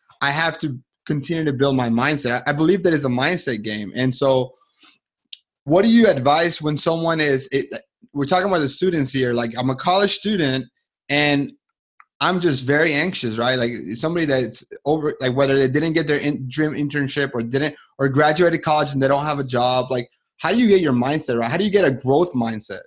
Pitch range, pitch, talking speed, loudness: 130-165 Hz, 145 Hz, 215 wpm, -19 LUFS